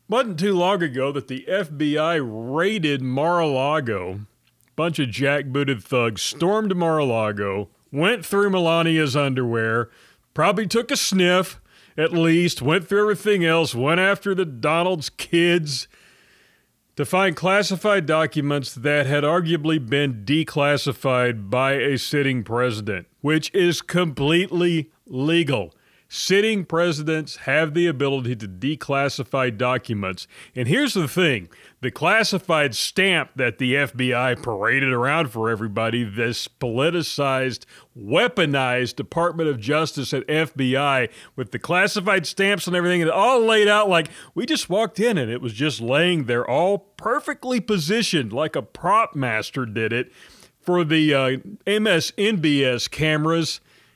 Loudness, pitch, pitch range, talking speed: -21 LUFS, 155 Hz, 130-180 Hz, 130 wpm